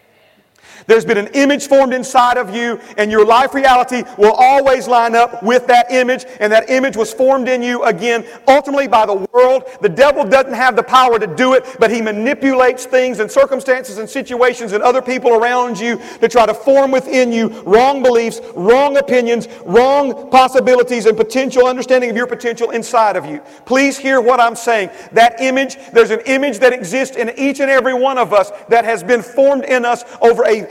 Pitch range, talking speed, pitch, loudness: 230-260 Hz, 195 wpm, 245 Hz, -13 LUFS